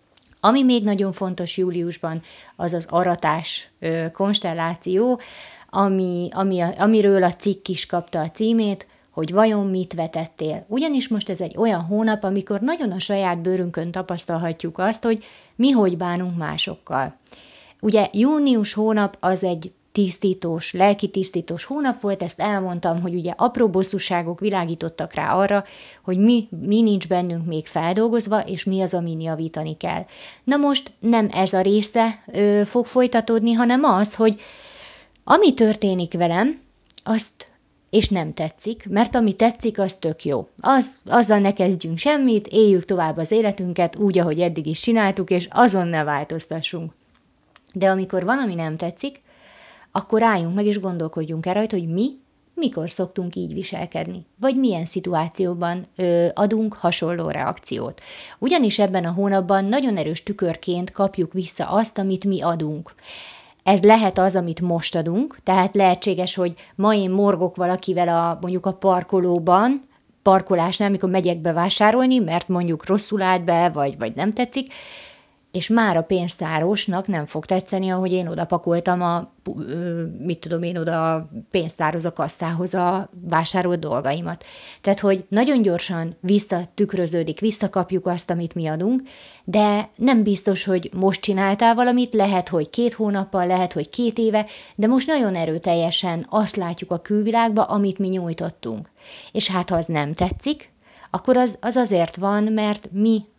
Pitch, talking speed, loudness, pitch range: 190 Hz, 145 wpm, -20 LUFS, 175-215 Hz